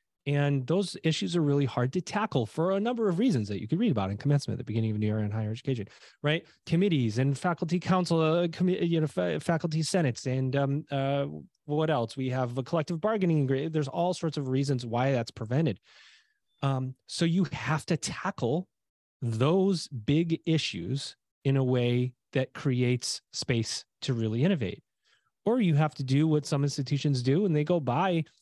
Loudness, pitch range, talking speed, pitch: -29 LUFS, 130-170 Hz, 190 wpm, 145 Hz